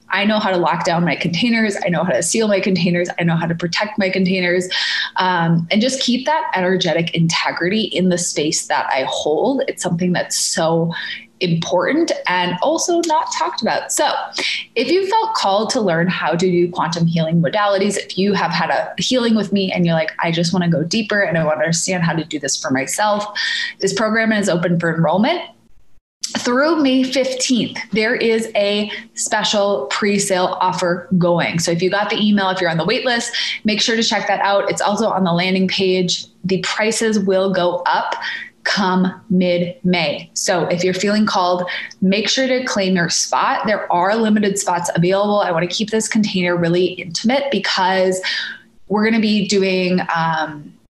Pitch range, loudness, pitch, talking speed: 175-220 Hz, -17 LUFS, 190 Hz, 195 wpm